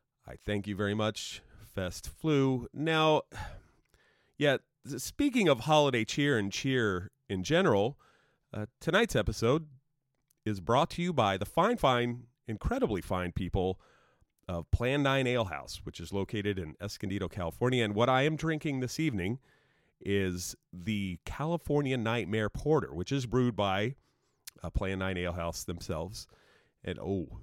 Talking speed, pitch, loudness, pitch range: 145 wpm, 110 Hz, -31 LUFS, 95-135 Hz